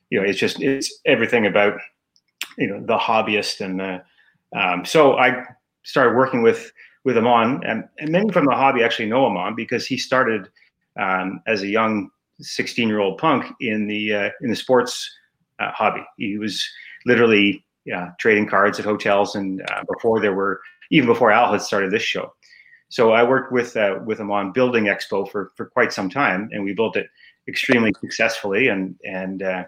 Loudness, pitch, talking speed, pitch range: -20 LUFS, 105 Hz, 185 wpm, 100-120 Hz